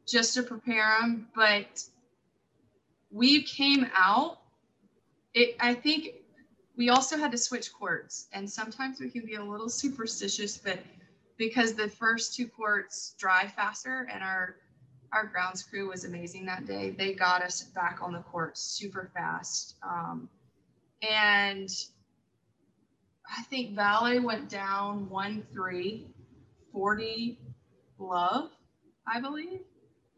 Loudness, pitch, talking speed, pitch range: -29 LUFS, 210 Hz, 125 wpm, 185-240 Hz